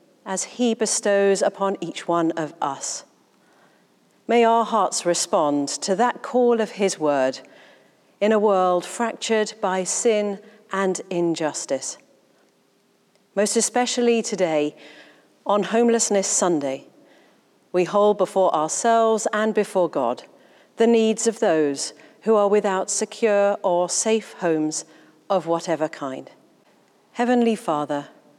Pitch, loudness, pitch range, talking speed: 200 Hz, -21 LUFS, 170-220 Hz, 115 wpm